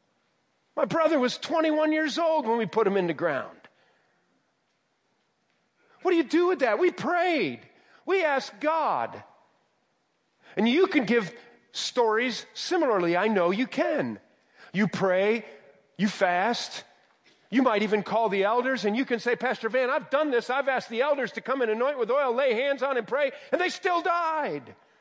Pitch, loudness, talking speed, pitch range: 260 Hz, -26 LUFS, 175 wpm, 220-315 Hz